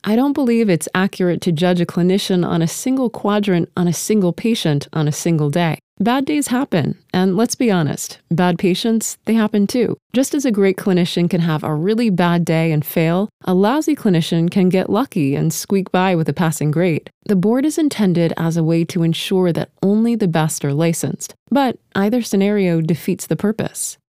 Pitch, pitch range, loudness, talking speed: 185 Hz, 165-215 Hz, -17 LUFS, 200 wpm